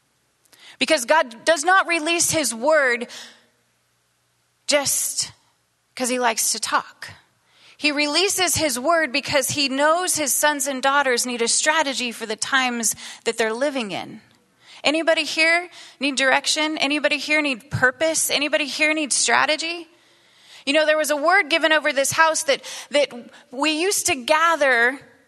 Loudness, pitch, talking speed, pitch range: -19 LUFS, 295 Hz, 145 wpm, 255-320 Hz